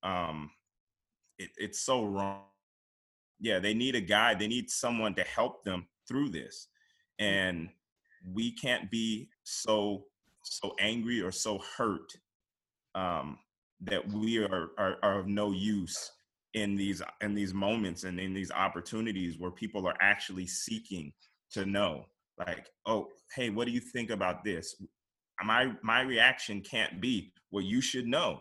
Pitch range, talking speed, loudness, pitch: 95-110 Hz, 150 wpm, -32 LUFS, 100 Hz